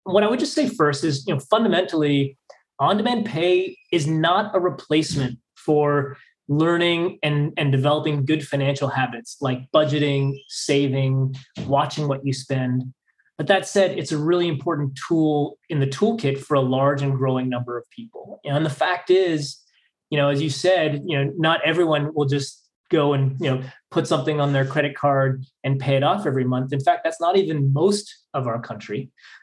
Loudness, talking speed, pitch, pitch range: -22 LUFS, 185 wpm, 150 Hz, 135-170 Hz